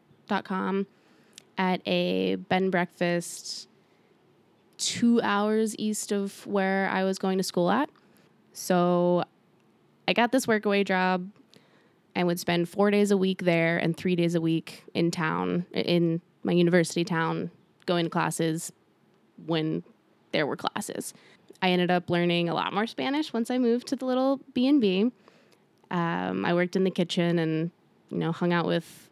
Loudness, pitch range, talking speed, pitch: -27 LUFS, 170-205 Hz, 155 wpm, 180 Hz